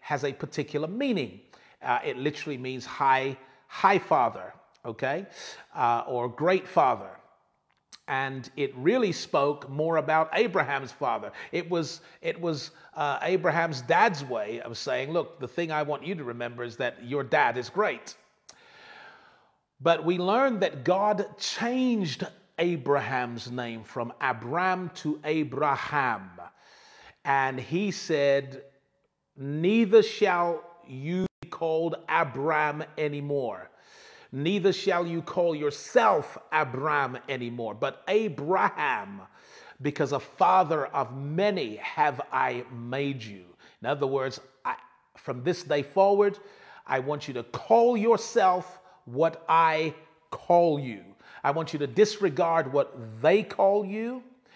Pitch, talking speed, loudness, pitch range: 155 Hz, 125 wpm, -27 LUFS, 135-185 Hz